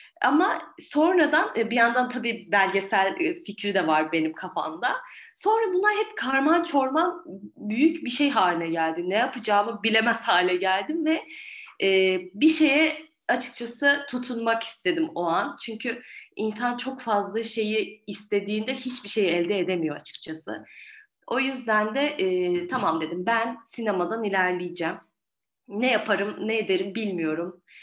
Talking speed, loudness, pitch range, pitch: 125 wpm, -25 LUFS, 190-270 Hz, 225 Hz